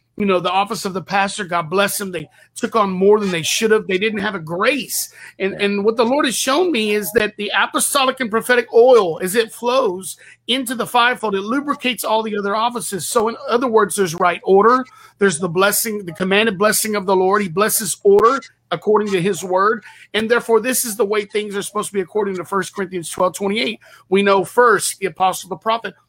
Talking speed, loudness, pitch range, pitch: 225 wpm, -17 LUFS, 195-230 Hz, 210 Hz